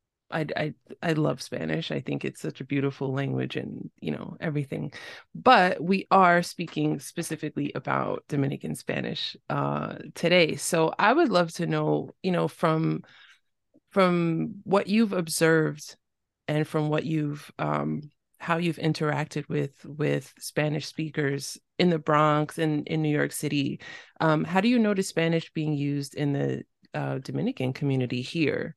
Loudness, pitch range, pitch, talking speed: -27 LUFS, 140-165 Hz, 150 Hz, 155 wpm